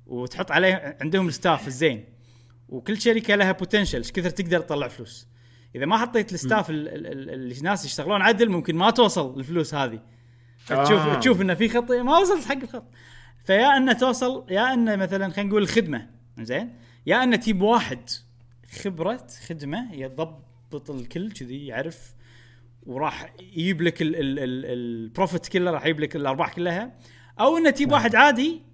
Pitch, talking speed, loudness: 165 Hz, 160 wpm, -23 LUFS